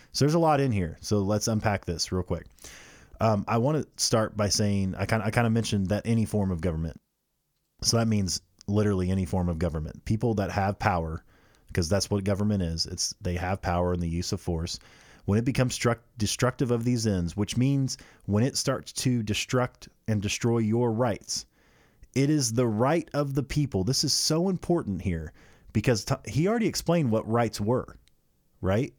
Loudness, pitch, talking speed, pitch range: -27 LUFS, 110 Hz, 195 wpm, 95-125 Hz